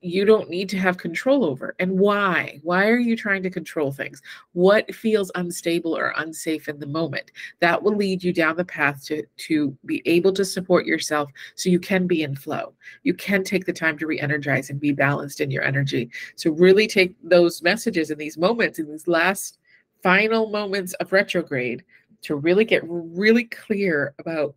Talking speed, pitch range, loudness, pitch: 190 wpm, 155-195 Hz, -22 LUFS, 180 Hz